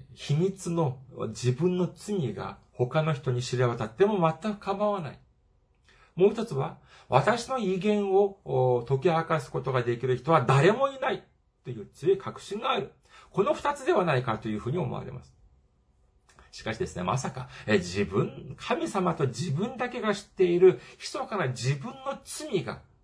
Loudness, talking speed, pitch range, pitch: -28 LUFS, 295 characters per minute, 125-205 Hz, 165 Hz